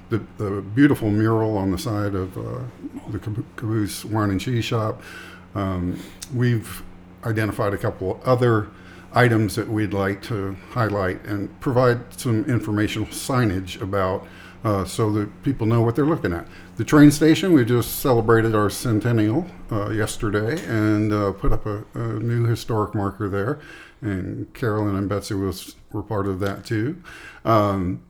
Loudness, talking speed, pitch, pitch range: -22 LUFS, 160 wpm, 105 Hz, 100-115 Hz